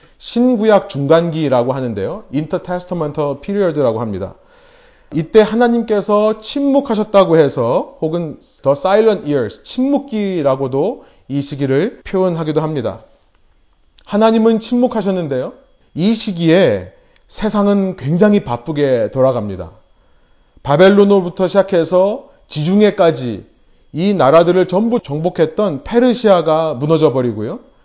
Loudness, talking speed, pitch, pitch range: -15 LUFS, 335 characters per minute, 185 Hz, 145-215 Hz